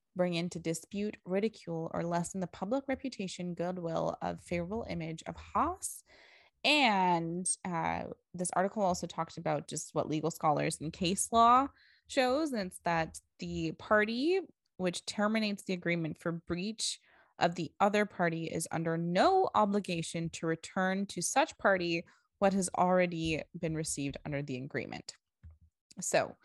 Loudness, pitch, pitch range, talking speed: -33 LUFS, 180 Hz, 165-205 Hz, 145 wpm